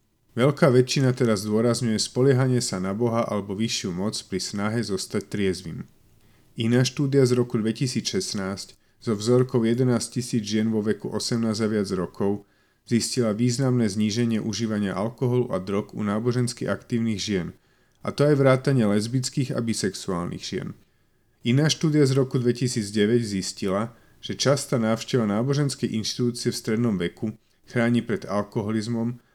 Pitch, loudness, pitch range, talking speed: 115 Hz, -24 LUFS, 105-125 Hz, 140 wpm